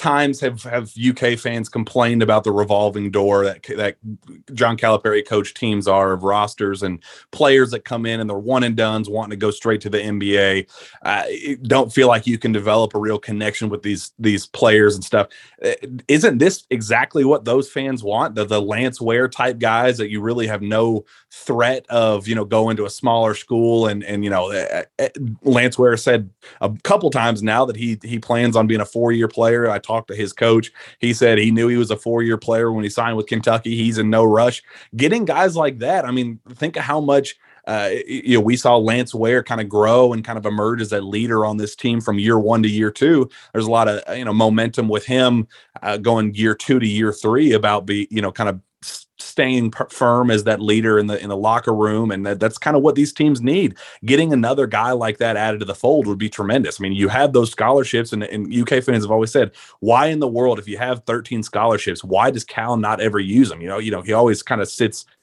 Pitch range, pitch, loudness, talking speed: 105-120 Hz, 115 Hz, -18 LUFS, 230 wpm